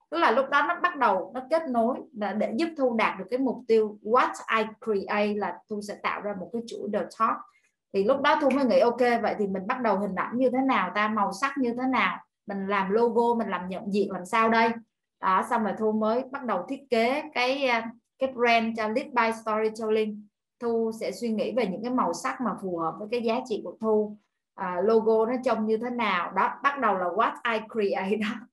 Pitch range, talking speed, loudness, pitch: 210-250 Hz, 240 wpm, -26 LUFS, 225 Hz